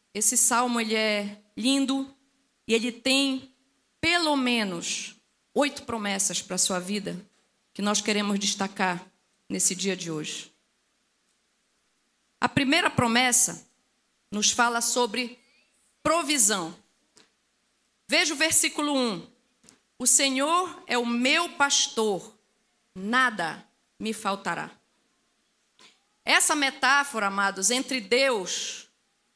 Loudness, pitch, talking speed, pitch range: -24 LUFS, 235 Hz, 100 wpm, 205-270 Hz